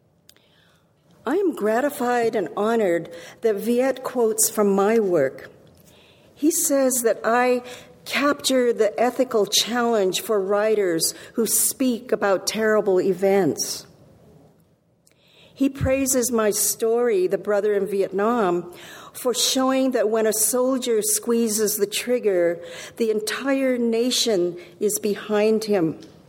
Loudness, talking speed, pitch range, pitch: -21 LUFS, 110 wpm, 205-245 Hz, 220 Hz